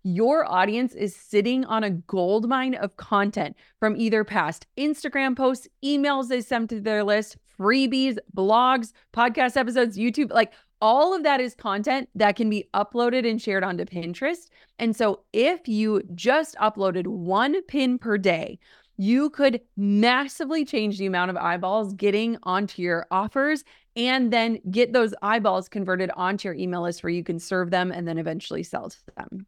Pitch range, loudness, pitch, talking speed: 195-255 Hz, -24 LUFS, 220 Hz, 165 wpm